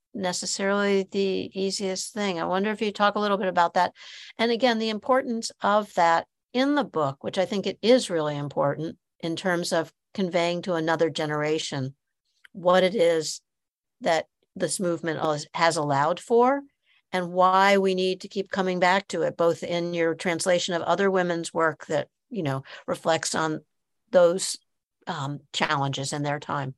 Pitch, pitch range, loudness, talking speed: 180 Hz, 160-195 Hz, -25 LUFS, 170 wpm